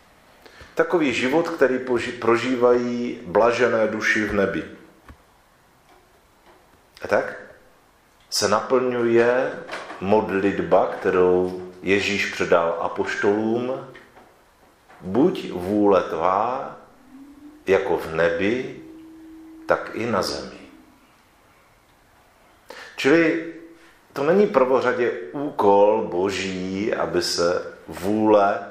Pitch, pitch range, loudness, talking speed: 120 Hz, 100-165 Hz, -21 LUFS, 75 wpm